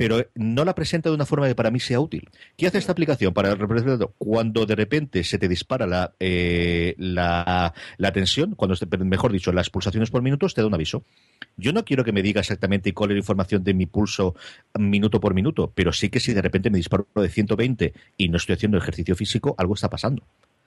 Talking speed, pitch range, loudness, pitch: 225 wpm, 95-120 Hz, -23 LUFS, 105 Hz